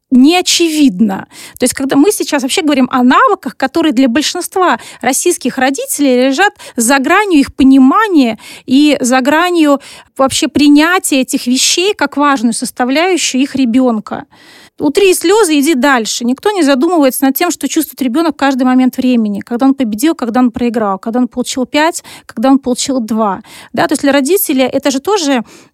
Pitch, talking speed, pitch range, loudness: 275 Hz, 165 wpm, 255-315 Hz, -11 LUFS